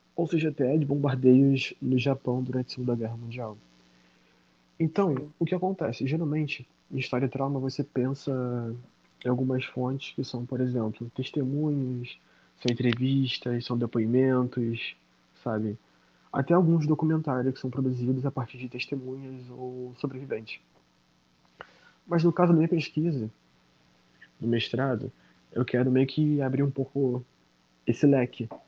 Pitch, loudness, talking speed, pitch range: 130 Hz, -28 LUFS, 135 wpm, 120-140 Hz